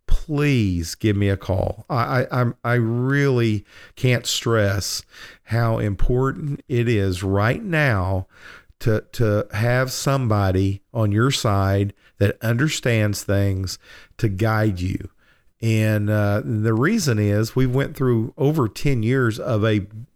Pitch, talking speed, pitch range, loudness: 110 Hz, 130 wpm, 100-125 Hz, -21 LUFS